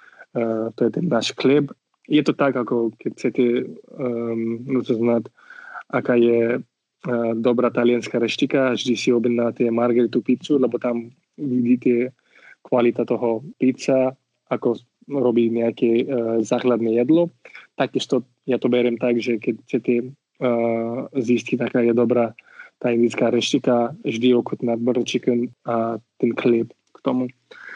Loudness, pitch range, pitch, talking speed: -21 LUFS, 115-125 Hz, 120 Hz, 130 wpm